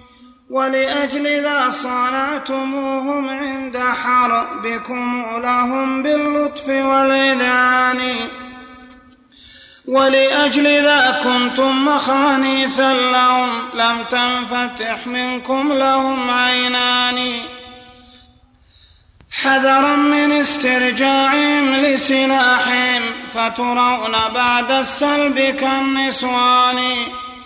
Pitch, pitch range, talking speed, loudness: 255 Hz, 250-270 Hz, 55 wpm, -15 LUFS